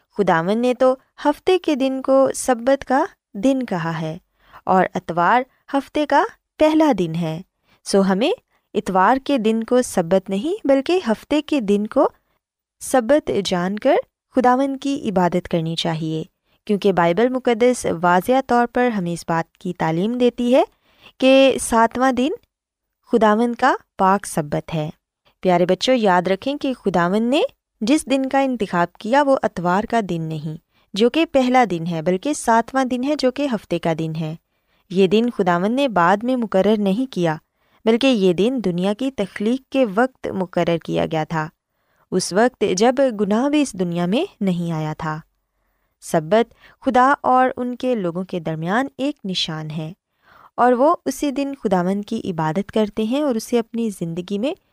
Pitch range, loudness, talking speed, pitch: 180-265 Hz, -19 LUFS, 165 wpm, 220 Hz